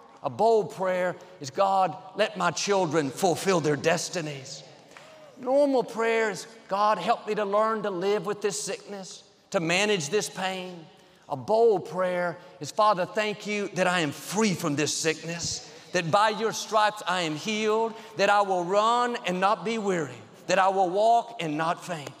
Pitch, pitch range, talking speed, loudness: 190 Hz, 175-215 Hz, 170 wpm, -26 LUFS